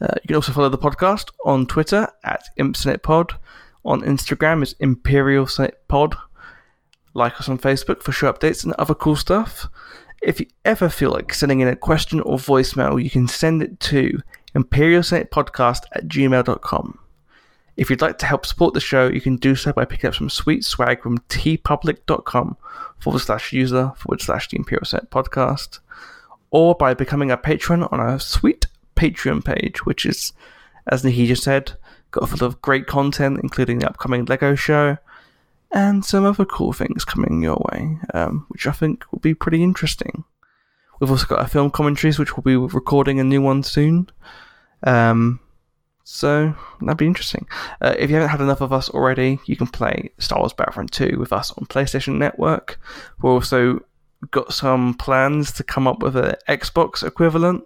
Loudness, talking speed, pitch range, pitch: -19 LUFS, 175 wpm, 130-155 Hz, 140 Hz